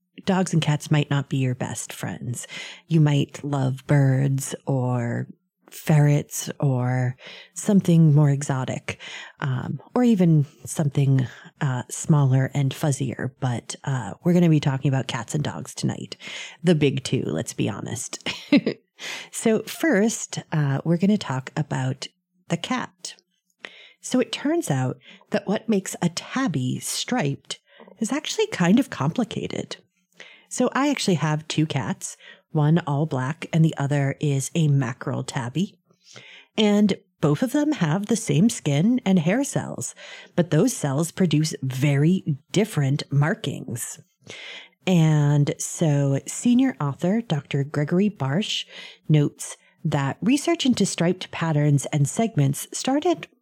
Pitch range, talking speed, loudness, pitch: 140-195 Hz, 135 wpm, -23 LUFS, 155 Hz